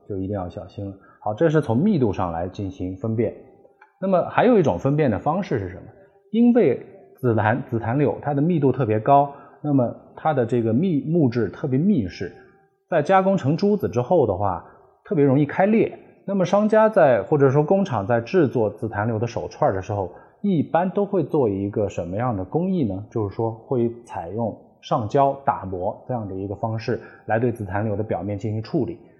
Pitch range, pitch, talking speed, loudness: 105-155 Hz, 125 Hz, 290 characters per minute, -22 LUFS